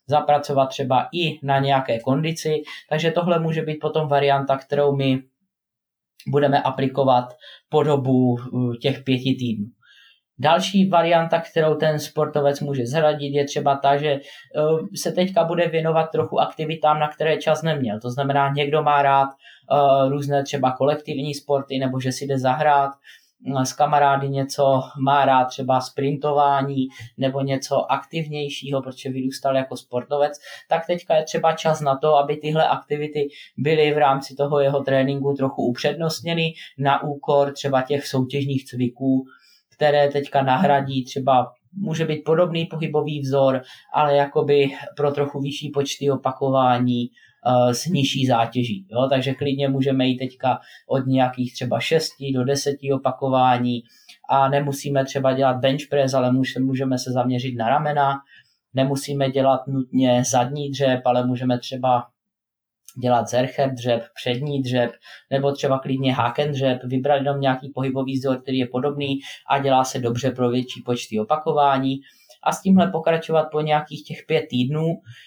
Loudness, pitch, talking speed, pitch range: -21 LUFS, 140 Hz, 145 wpm, 130-150 Hz